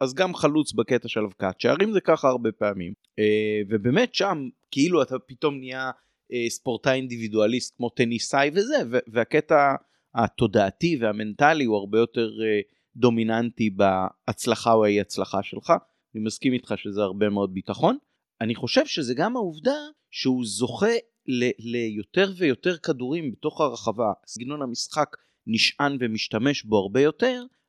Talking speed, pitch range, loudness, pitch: 130 wpm, 110-155 Hz, -24 LUFS, 125 Hz